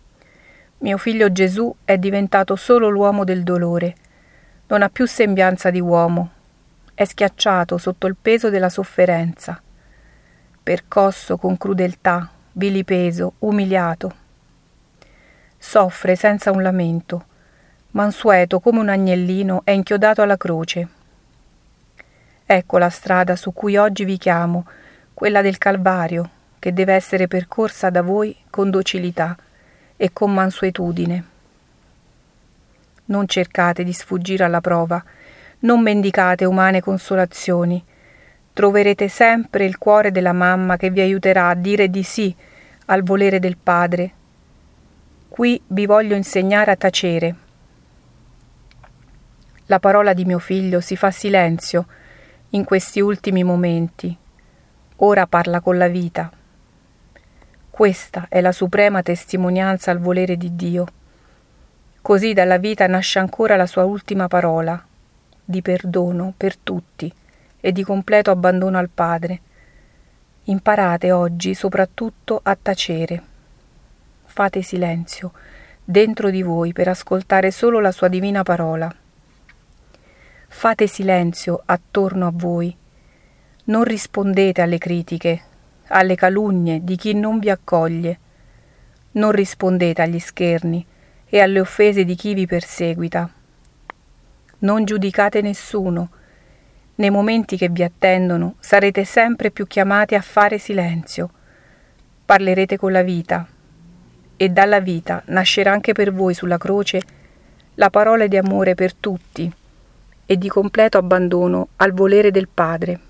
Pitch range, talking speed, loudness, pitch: 175-200 Hz, 120 wpm, -17 LUFS, 185 Hz